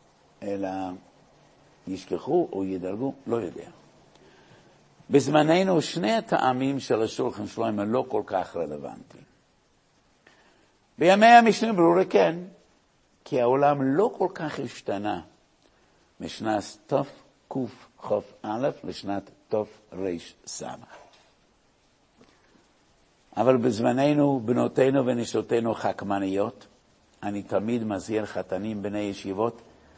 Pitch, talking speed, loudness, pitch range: 115 Hz, 90 wpm, -25 LUFS, 100-140 Hz